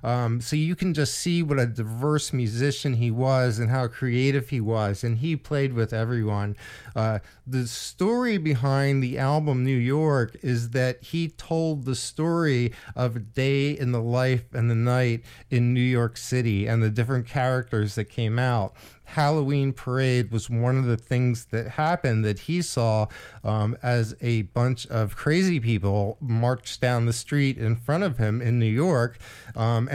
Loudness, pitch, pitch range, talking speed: -25 LUFS, 125 Hz, 115-135 Hz, 175 wpm